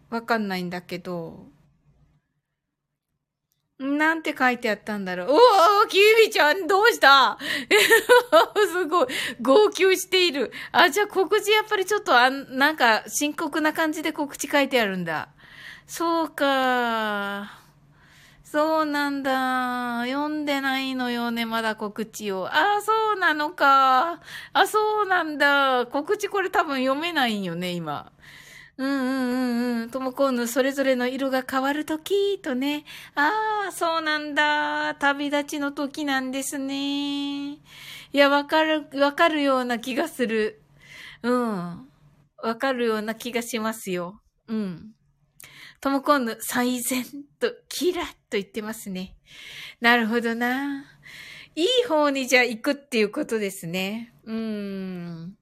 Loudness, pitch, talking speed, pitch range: -22 LUFS, 270 Hz, 260 characters per minute, 225-310 Hz